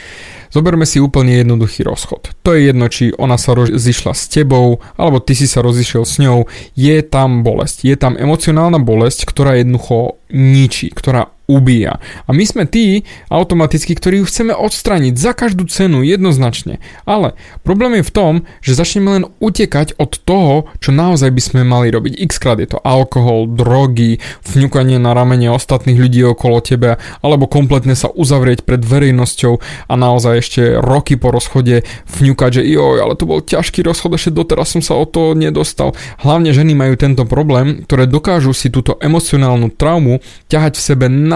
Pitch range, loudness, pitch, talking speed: 125-160 Hz, -11 LUFS, 135 Hz, 170 wpm